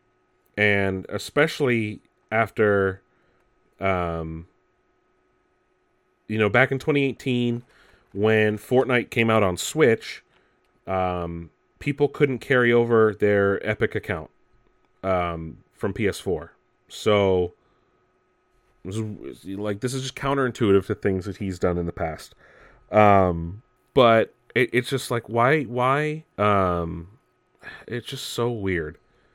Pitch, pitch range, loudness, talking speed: 105 Hz, 95-125 Hz, -23 LUFS, 110 wpm